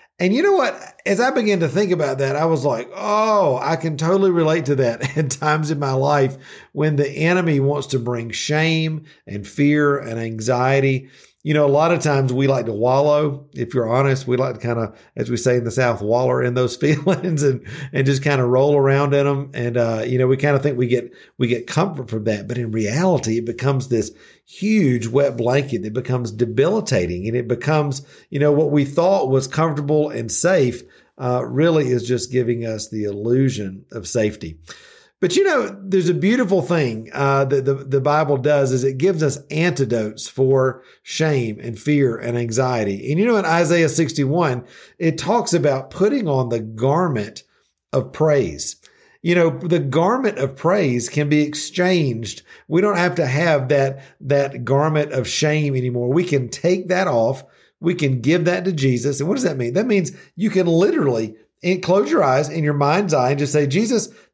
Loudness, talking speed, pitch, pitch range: -19 LUFS, 200 wpm, 140 Hz, 125-165 Hz